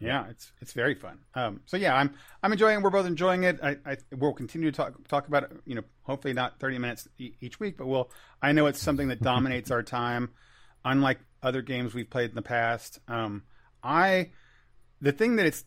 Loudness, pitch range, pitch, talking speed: -28 LUFS, 125-150 Hz, 135 Hz, 220 wpm